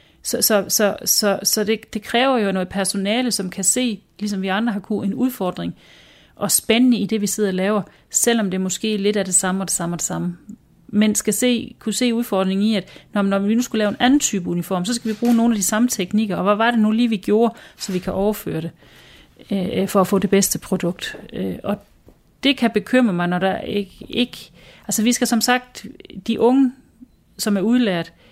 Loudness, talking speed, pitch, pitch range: -19 LUFS, 225 wpm, 210 Hz, 190-235 Hz